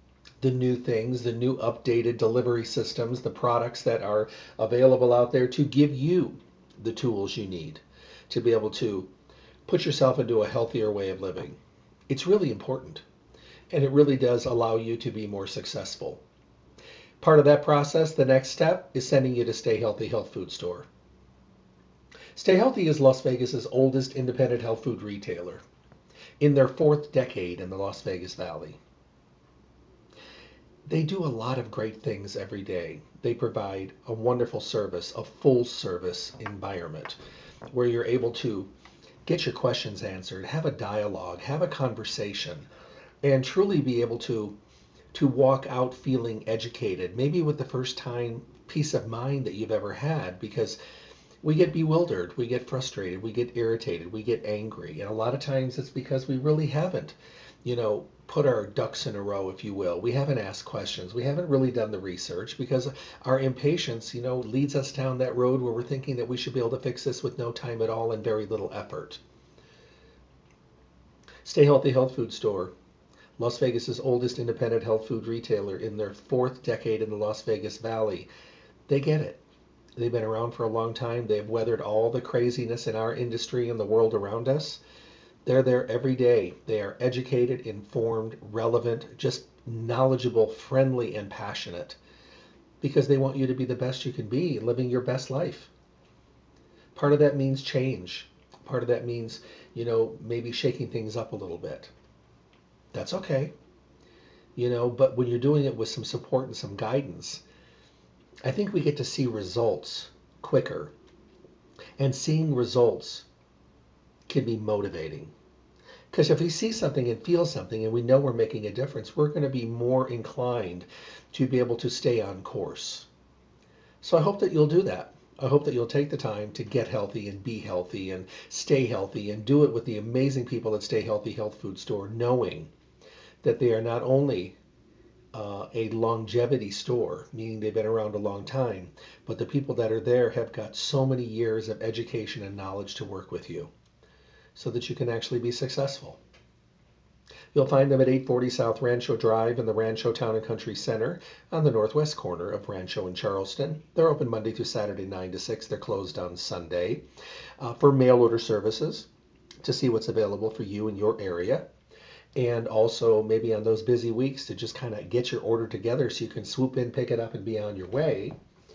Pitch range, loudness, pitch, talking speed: 110-135 Hz, -27 LUFS, 120 Hz, 185 wpm